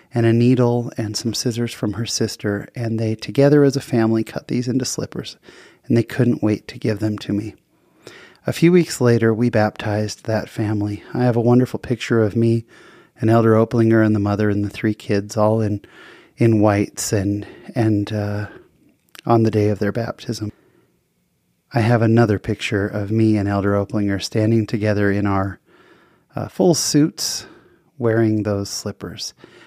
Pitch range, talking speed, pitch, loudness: 105-120 Hz, 170 wpm, 110 Hz, -19 LUFS